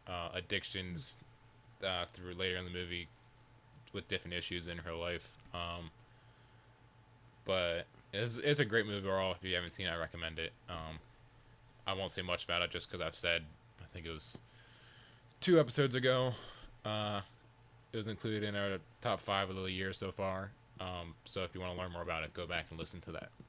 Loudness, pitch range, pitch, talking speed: -38 LUFS, 90-125 Hz, 100 Hz, 195 wpm